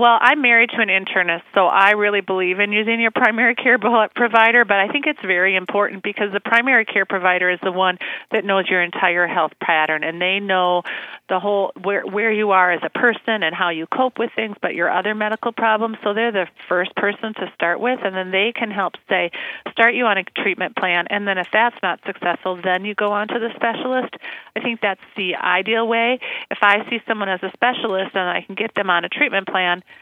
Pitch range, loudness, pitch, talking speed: 185-230 Hz, -18 LUFS, 205 Hz, 230 wpm